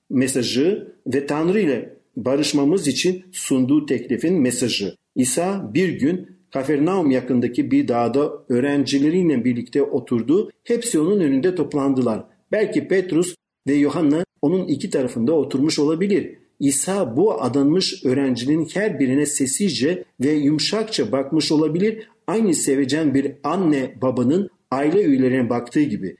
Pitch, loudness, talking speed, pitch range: 145 Hz, -20 LUFS, 120 wpm, 130-180 Hz